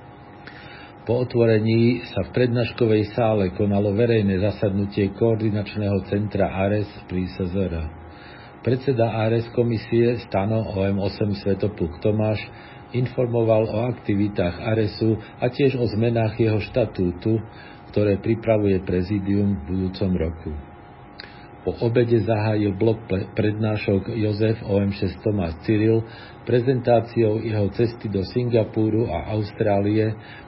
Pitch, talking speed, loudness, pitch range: 110 Hz, 100 wpm, -22 LUFS, 100-115 Hz